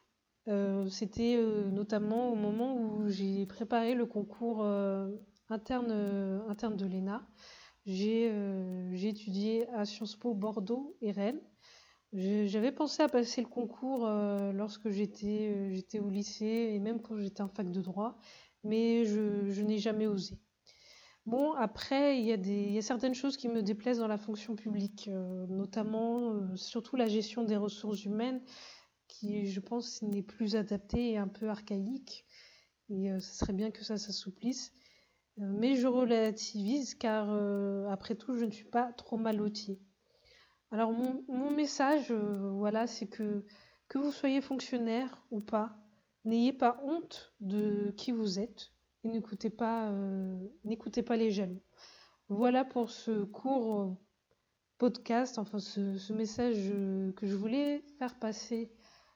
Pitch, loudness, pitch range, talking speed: 215 Hz, -35 LUFS, 205-235 Hz, 155 wpm